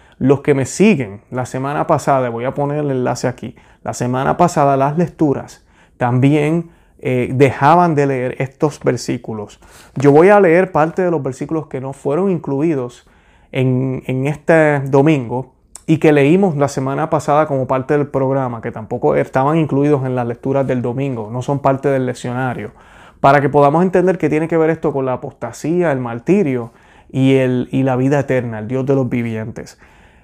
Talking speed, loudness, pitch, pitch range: 180 wpm, -16 LUFS, 135 Hz, 125-150 Hz